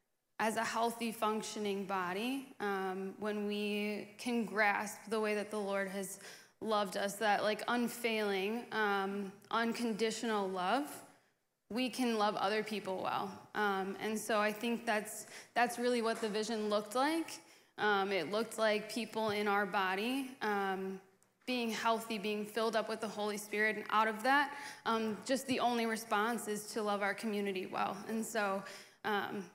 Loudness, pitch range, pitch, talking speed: -36 LUFS, 205-225 Hz, 215 Hz, 160 wpm